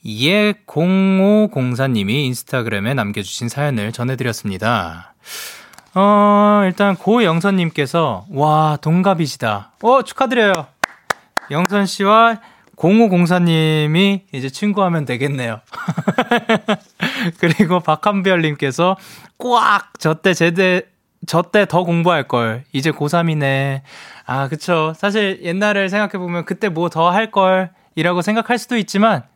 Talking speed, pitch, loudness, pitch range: 250 characters per minute, 175 Hz, -16 LUFS, 140-200 Hz